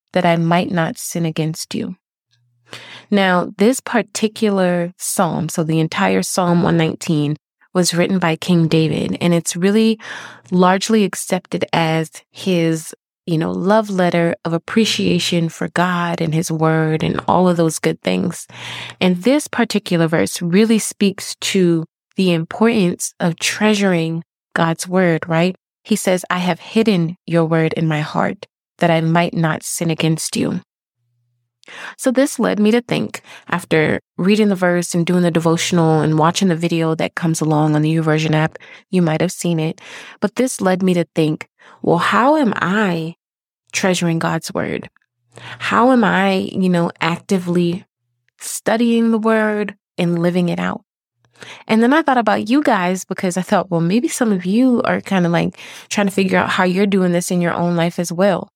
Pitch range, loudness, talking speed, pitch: 165-200 Hz, -17 LUFS, 170 wpm, 175 Hz